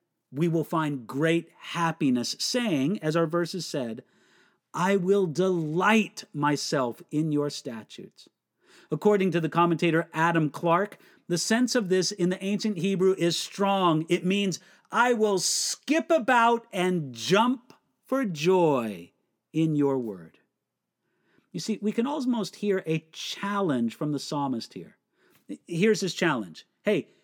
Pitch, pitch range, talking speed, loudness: 175 Hz, 155-200 Hz, 135 wpm, -26 LUFS